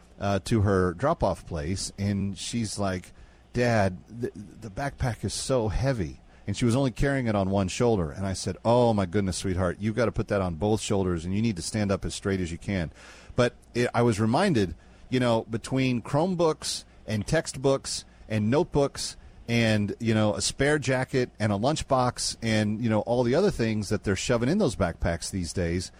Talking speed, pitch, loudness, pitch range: 200 wpm, 105 Hz, -27 LUFS, 95-120 Hz